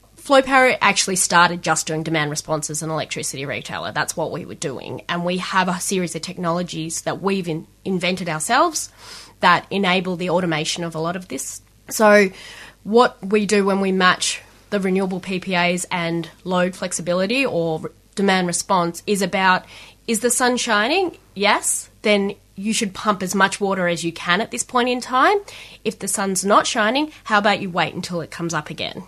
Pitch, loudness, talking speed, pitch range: 185 Hz, -20 LUFS, 185 wpm, 170-210 Hz